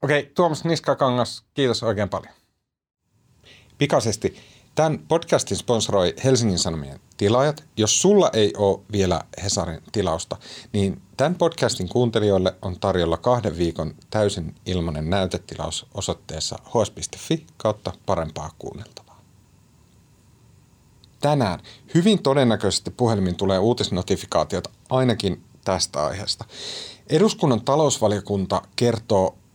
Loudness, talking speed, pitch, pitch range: -22 LUFS, 95 wpm, 105 Hz, 95-130 Hz